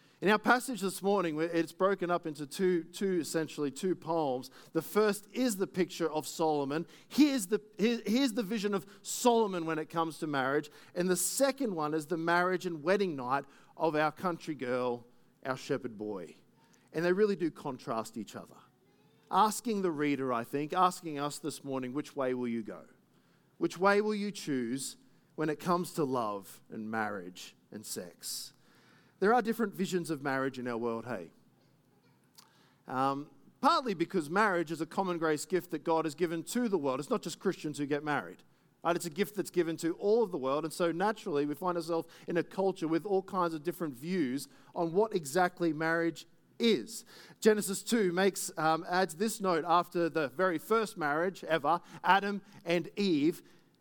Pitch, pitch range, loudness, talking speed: 170 Hz, 150-195 Hz, -32 LUFS, 185 wpm